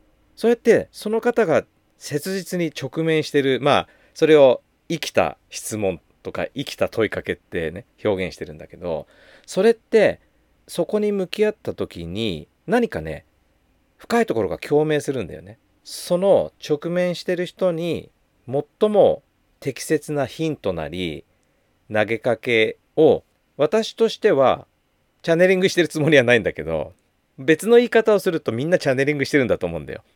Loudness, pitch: -21 LUFS, 150 Hz